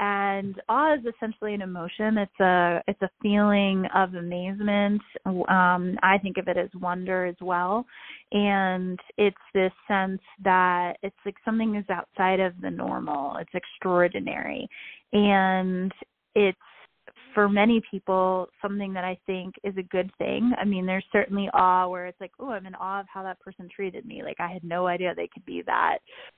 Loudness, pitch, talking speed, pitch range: -26 LUFS, 190 Hz, 175 wpm, 185-205 Hz